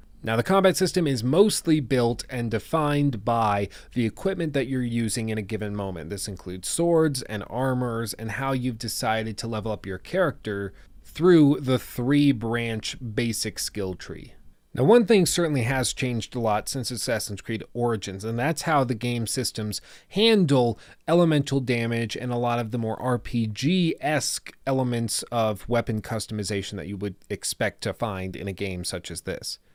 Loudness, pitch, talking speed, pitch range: -25 LUFS, 120 Hz, 170 wpm, 105-135 Hz